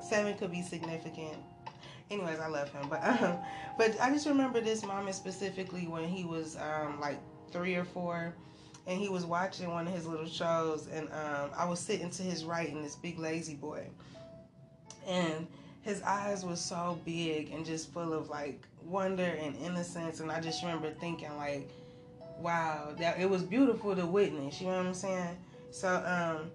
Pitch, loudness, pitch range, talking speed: 170 Hz, -35 LUFS, 155-185 Hz, 185 wpm